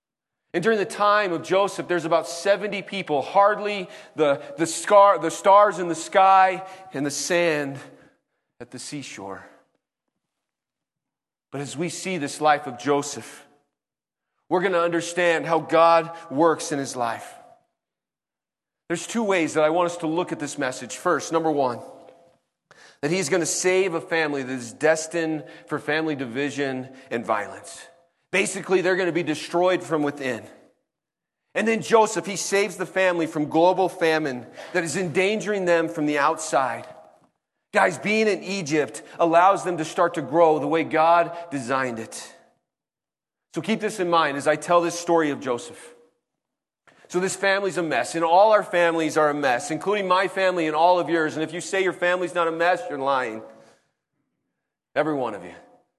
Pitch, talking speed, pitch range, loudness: 165 Hz, 170 wpm, 150-185 Hz, -22 LUFS